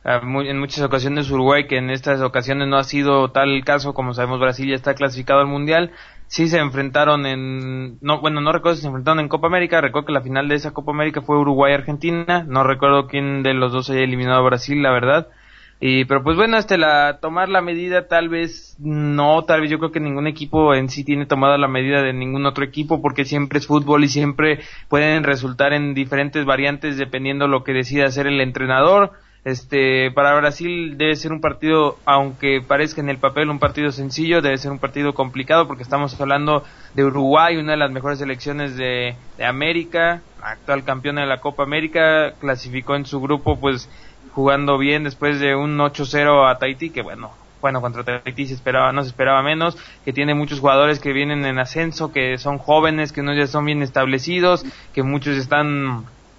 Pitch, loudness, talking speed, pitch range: 140 Hz, -18 LUFS, 205 wpm, 135-150 Hz